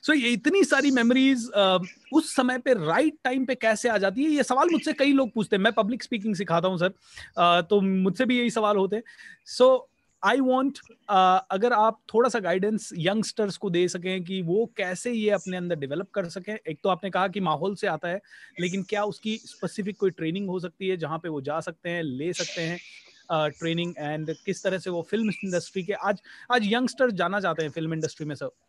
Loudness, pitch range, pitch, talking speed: -25 LUFS, 180-240 Hz, 200 Hz, 210 wpm